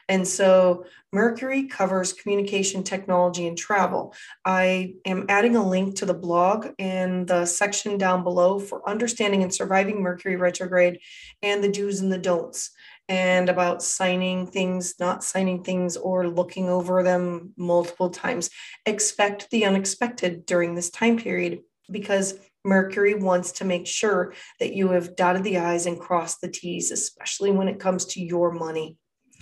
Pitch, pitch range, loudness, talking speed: 185 Hz, 180-195 Hz, -24 LUFS, 155 wpm